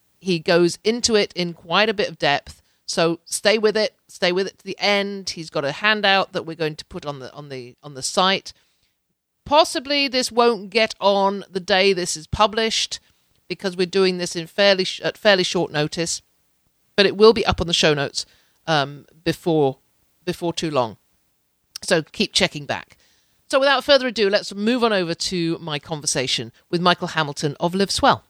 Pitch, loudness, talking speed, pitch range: 180 Hz, -20 LUFS, 195 wpm, 155-205 Hz